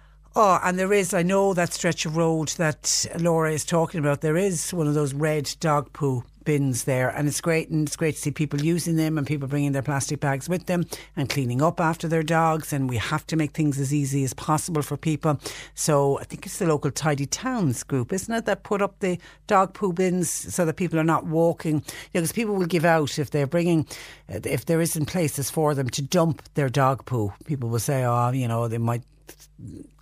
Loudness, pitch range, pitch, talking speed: -24 LUFS, 140-170 Hz, 155 Hz, 230 wpm